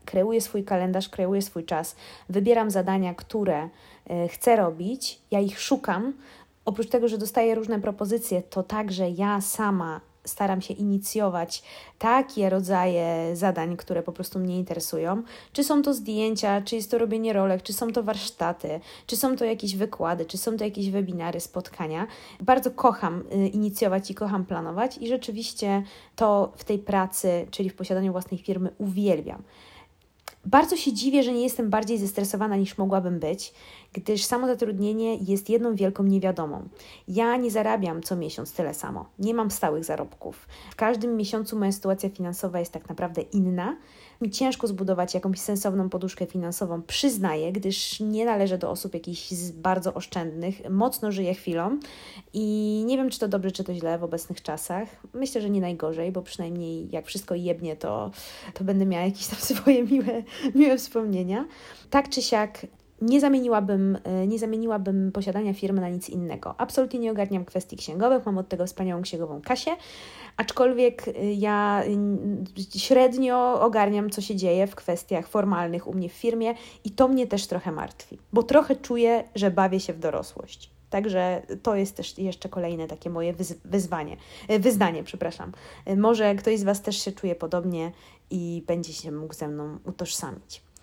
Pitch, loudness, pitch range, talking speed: 200 Hz, -26 LUFS, 180-225 Hz, 160 wpm